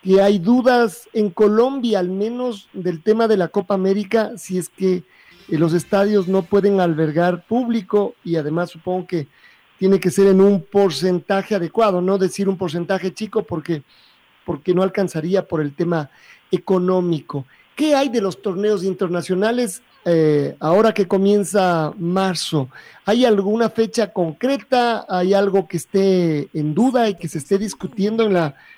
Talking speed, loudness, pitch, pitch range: 155 wpm, -19 LUFS, 195 Hz, 175-210 Hz